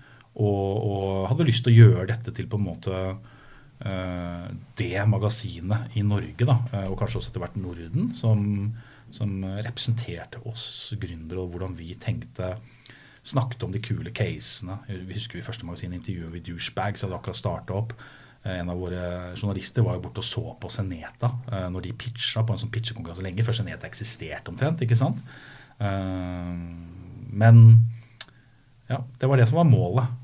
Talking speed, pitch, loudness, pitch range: 175 wpm, 115 Hz, -25 LUFS, 95-120 Hz